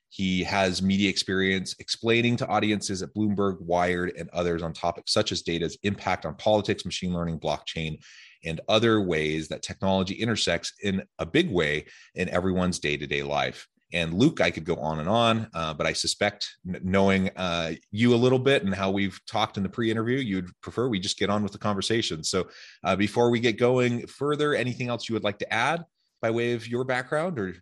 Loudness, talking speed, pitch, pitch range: -26 LUFS, 205 wpm, 100 Hz, 90-115 Hz